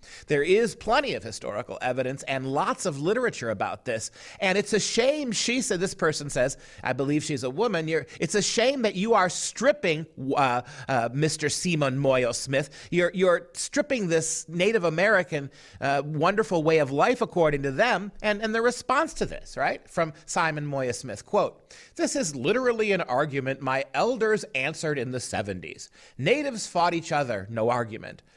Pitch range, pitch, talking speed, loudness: 135-205 Hz, 165 Hz, 175 wpm, -26 LUFS